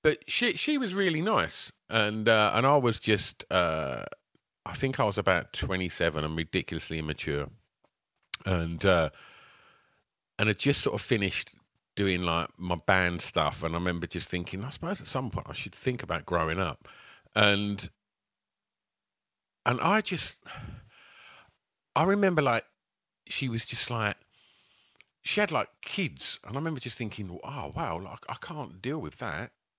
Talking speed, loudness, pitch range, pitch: 160 wpm, -29 LUFS, 90-135 Hz, 105 Hz